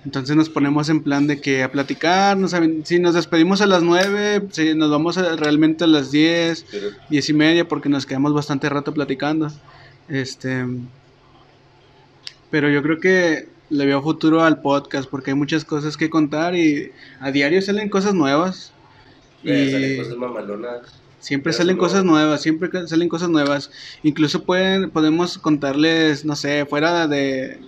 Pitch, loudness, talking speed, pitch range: 150 Hz, -18 LUFS, 165 wpm, 140-165 Hz